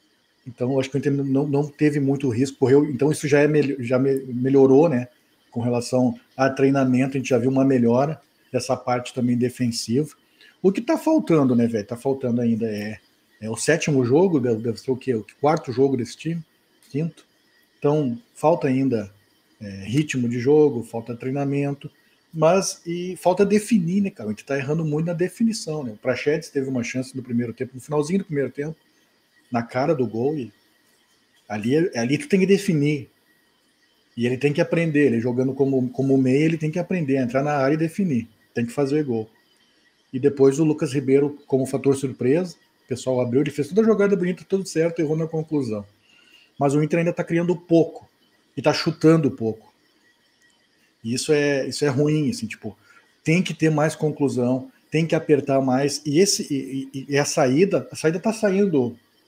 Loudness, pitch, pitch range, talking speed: -22 LUFS, 140 Hz, 125-155 Hz, 185 wpm